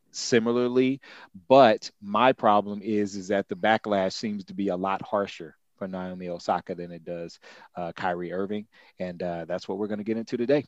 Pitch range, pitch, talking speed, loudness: 90-110 Hz, 100 Hz, 190 wpm, -26 LUFS